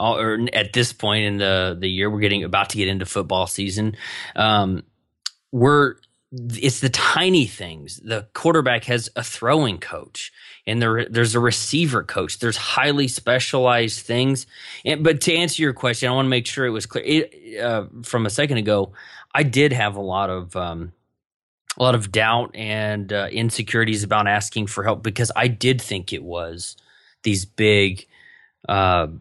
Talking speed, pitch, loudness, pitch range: 175 wpm, 110 Hz, -20 LUFS, 100-125 Hz